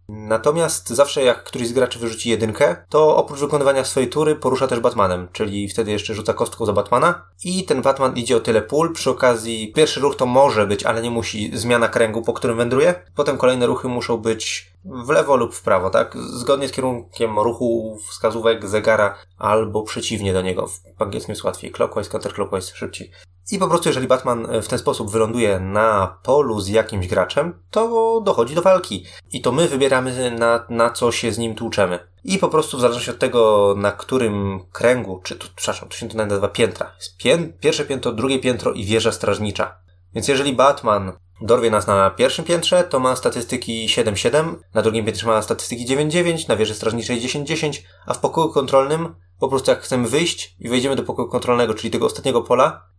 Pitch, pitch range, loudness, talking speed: 115 Hz, 105-135 Hz, -19 LUFS, 190 wpm